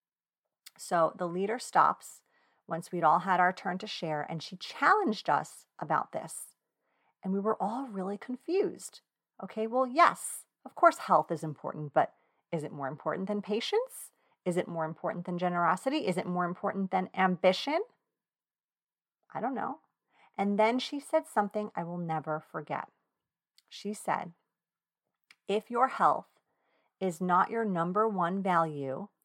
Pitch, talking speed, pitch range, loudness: 190 Hz, 150 wpm, 170-220 Hz, -31 LUFS